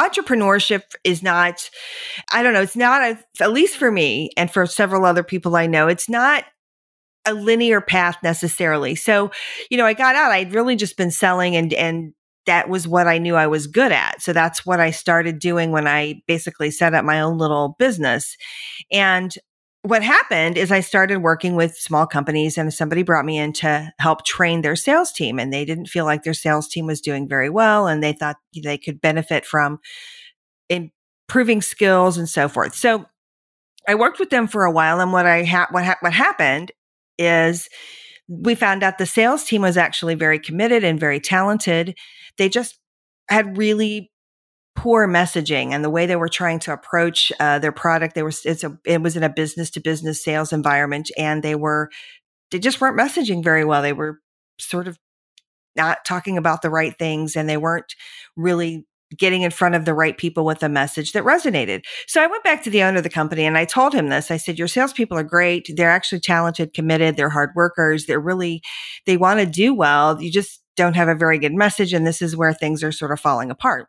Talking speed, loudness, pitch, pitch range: 205 wpm, -18 LUFS, 170 Hz, 155-200 Hz